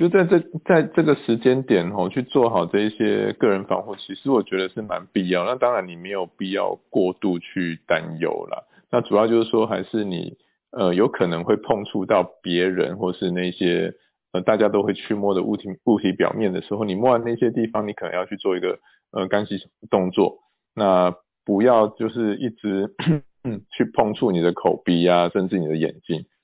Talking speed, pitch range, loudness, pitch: 285 characters per minute, 90-115 Hz, -22 LUFS, 105 Hz